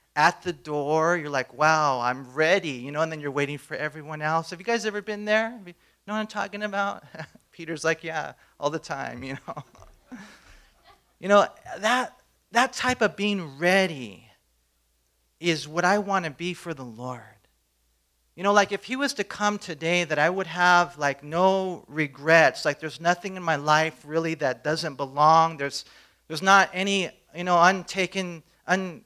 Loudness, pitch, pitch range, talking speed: -24 LUFS, 165 Hz, 145-190 Hz, 180 wpm